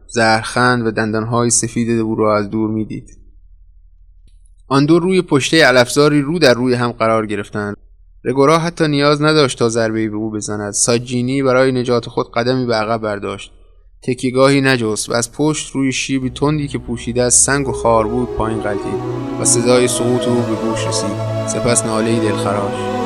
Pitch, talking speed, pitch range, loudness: 120 Hz, 165 wpm, 110-130 Hz, -15 LUFS